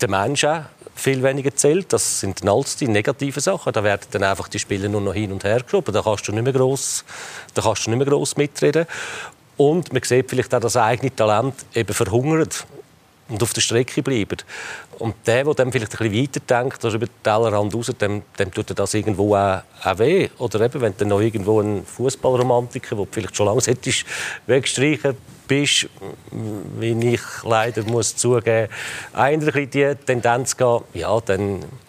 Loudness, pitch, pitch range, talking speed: -20 LUFS, 120 Hz, 105-135 Hz, 175 wpm